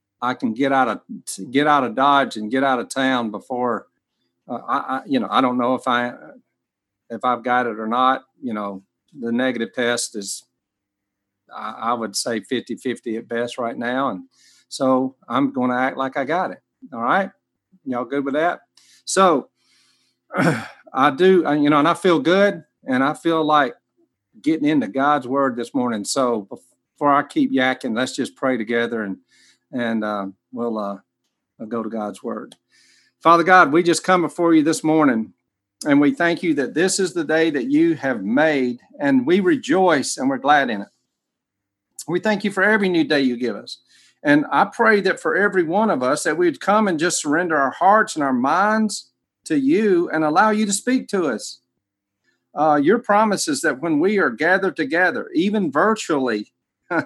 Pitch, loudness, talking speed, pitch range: 140 Hz, -19 LUFS, 195 wpm, 120-185 Hz